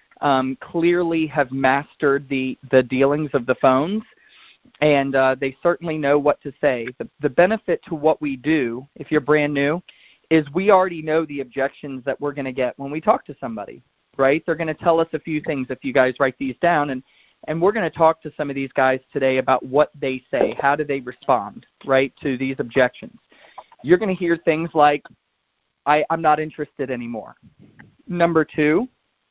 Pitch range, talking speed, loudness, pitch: 135-160 Hz, 200 wpm, -20 LUFS, 145 Hz